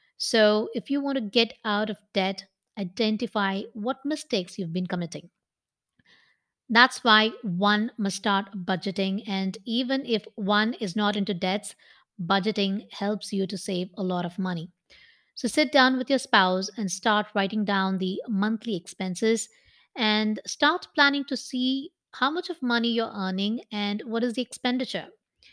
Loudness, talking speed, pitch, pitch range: -26 LUFS, 155 wpm, 210 Hz, 195-240 Hz